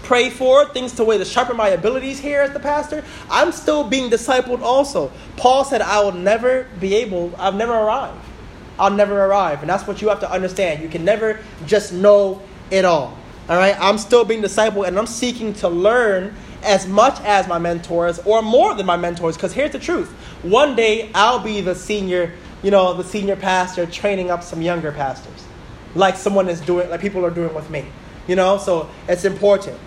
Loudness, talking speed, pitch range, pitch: -18 LUFS, 205 wpm, 180-225 Hz, 200 Hz